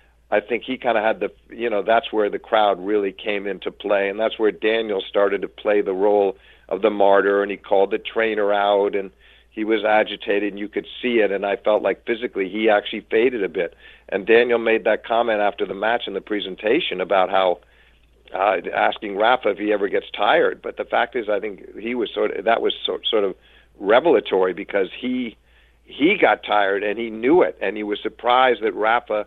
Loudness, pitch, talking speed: -20 LUFS, 110 Hz, 215 wpm